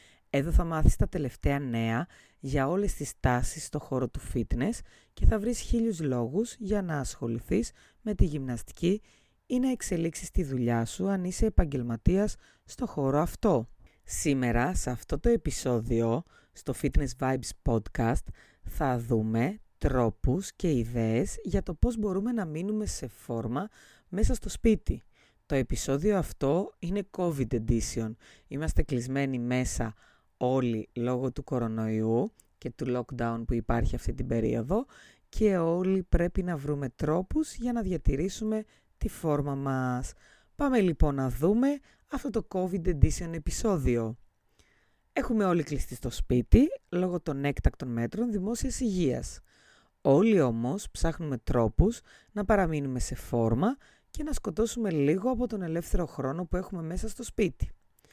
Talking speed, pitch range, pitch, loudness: 140 wpm, 120-195 Hz, 145 Hz, -30 LUFS